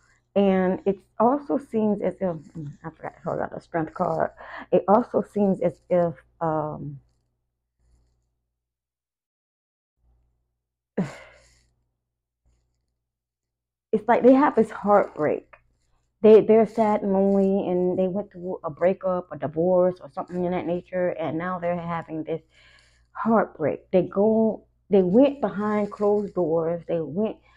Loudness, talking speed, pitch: -23 LUFS, 125 wpm, 175 Hz